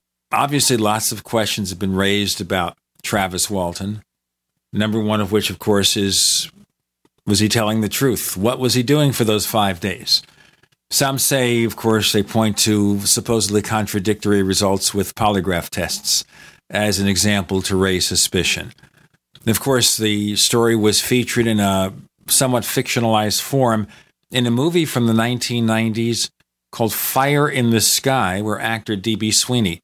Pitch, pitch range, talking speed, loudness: 105 Hz, 100-115 Hz, 150 wpm, -17 LUFS